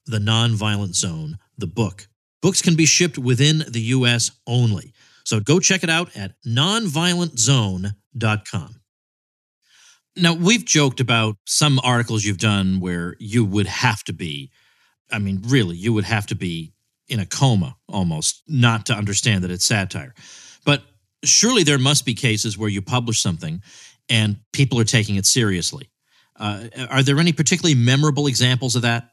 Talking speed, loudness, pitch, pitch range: 160 wpm, -19 LUFS, 115 Hz, 100-140 Hz